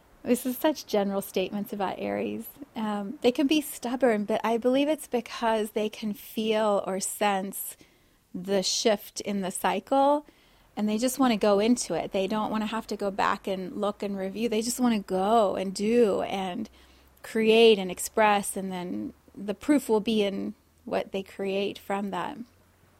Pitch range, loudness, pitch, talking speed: 195-235 Hz, -27 LUFS, 215 Hz, 185 wpm